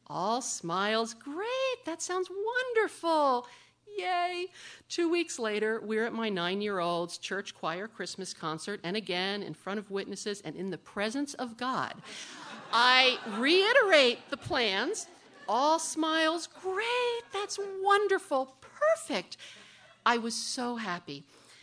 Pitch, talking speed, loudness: 250 Hz, 130 wpm, -30 LUFS